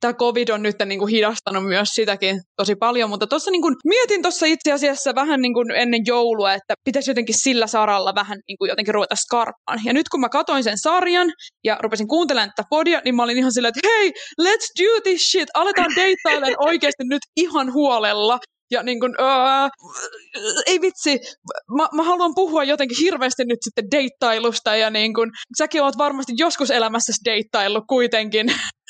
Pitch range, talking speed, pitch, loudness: 225-315 Hz, 185 wpm, 260 Hz, -19 LUFS